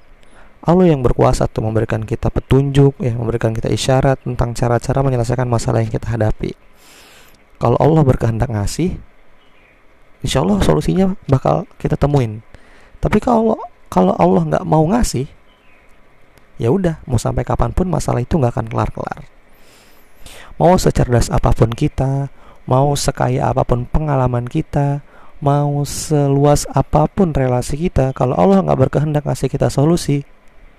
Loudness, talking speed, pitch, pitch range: -16 LUFS, 130 wpm, 135 Hz, 120-150 Hz